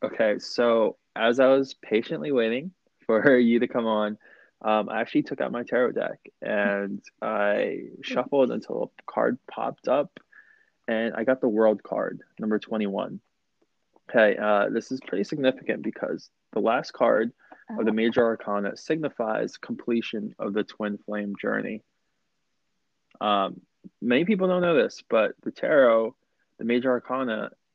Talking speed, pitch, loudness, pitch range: 150 wpm, 115 Hz, -25 LUFS, 105-130 Hz